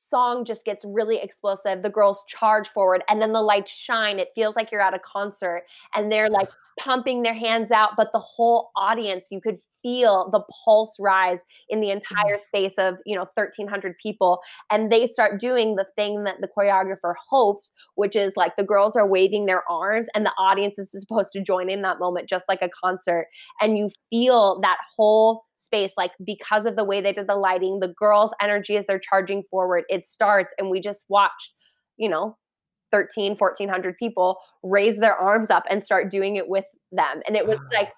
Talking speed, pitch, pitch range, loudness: 200 wpm, 205 Hz, 190-215 Hz, -22 LUFS